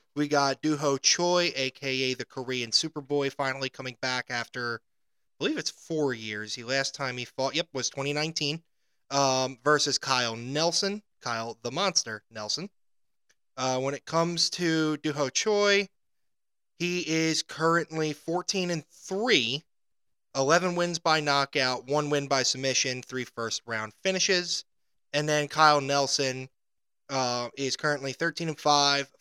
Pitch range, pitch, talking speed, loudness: 130-160 Hz, 140 Hz, 140 wpm, -27 LUFS